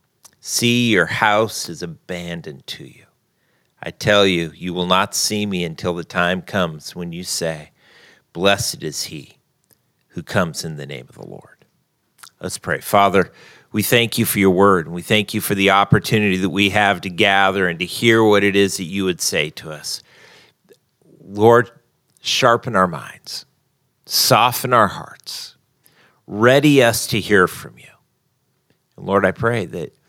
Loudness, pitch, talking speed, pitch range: -17 LUFS, 100 Hz, 170 wpm, 90-110 Hz